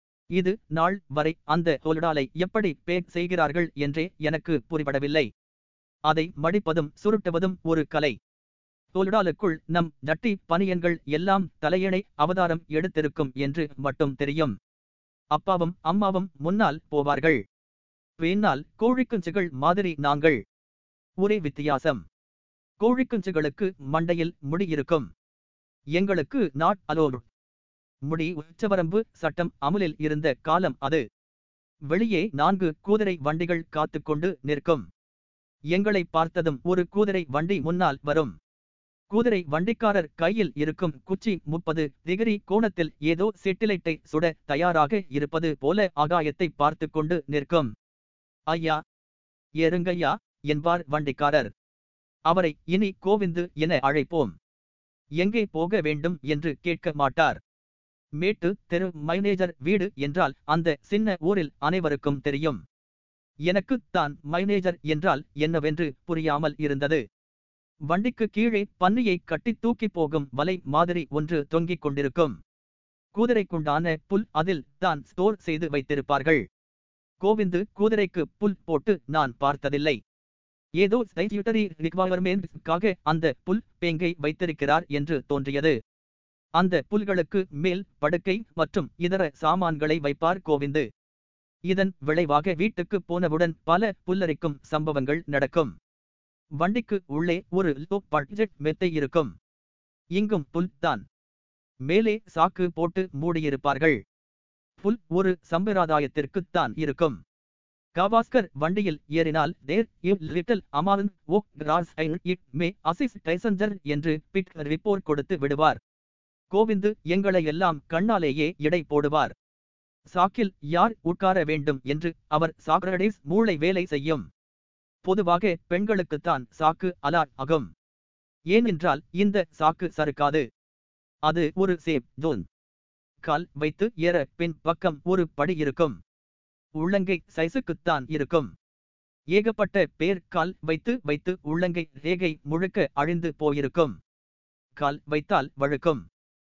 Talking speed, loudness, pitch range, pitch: 100 wpm, -26 LUFS, 145-185 Hz, 160 Hz